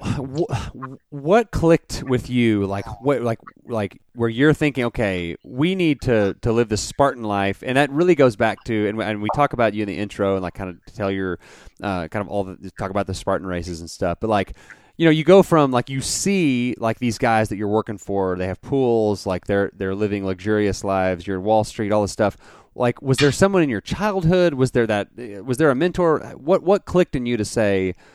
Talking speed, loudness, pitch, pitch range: 230 wpm, -20 LUFS, 110 Hz, 100-140 Hz